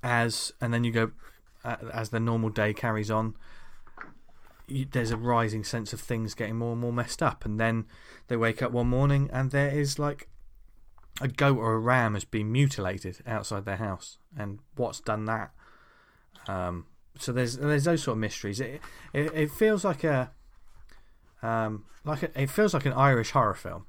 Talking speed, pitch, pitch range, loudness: 190 wpm, 115 Hz, 105-135 Hz, -29 LUFS